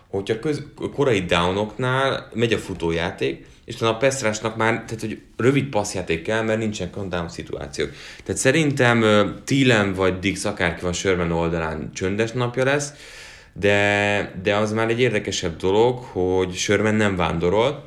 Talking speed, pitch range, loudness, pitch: 155 wpm, 95-115 Hz, -21 LUFS, 105 Hz